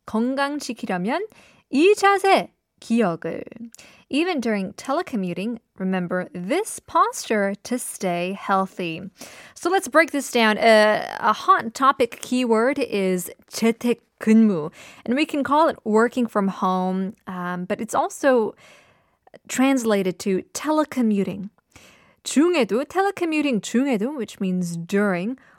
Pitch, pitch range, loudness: 230 Hz, 195-280 Hz, -22 LUFS